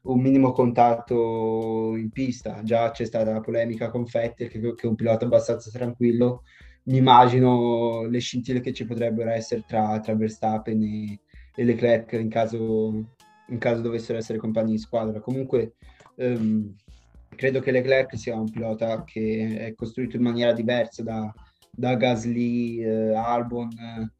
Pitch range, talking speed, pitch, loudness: 110-120 Hz, 155 wpm, 115 Hz, -24 LUFS